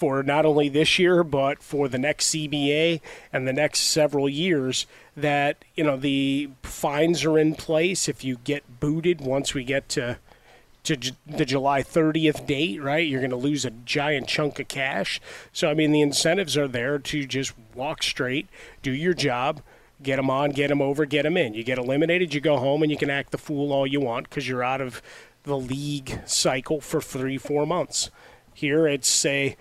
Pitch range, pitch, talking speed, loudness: 135-155 Hz, 145 Hz, 200 wpm, -24 LUFS